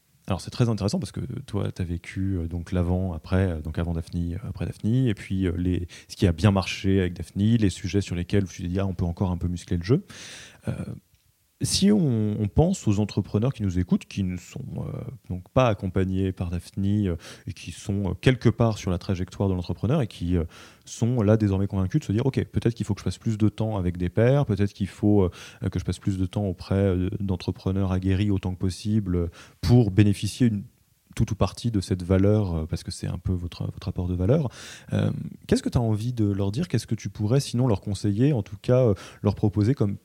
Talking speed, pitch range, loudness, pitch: 235 wpm, 95-115 Hz, -25 LUFS, 100 Hz